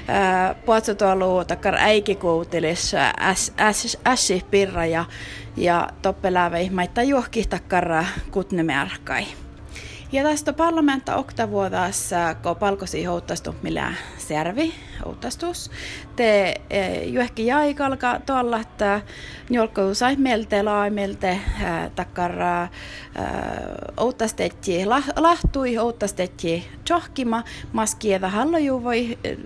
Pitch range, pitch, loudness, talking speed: 180-245 Hz, 205 Hz, -22 LUFS, 85 wpm